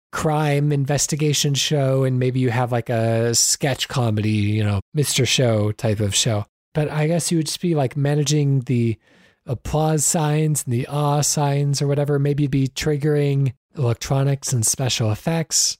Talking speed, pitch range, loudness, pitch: 165 wpm, 120-150 Hz, -20 LUFS, 140 Hz